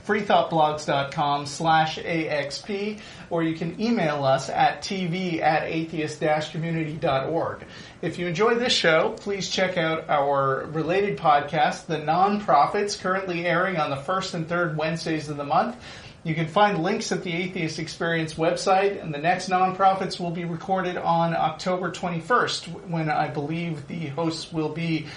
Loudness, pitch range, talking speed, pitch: -24 LUFS, 155-185 Hz, 150 wpm, 170 Hz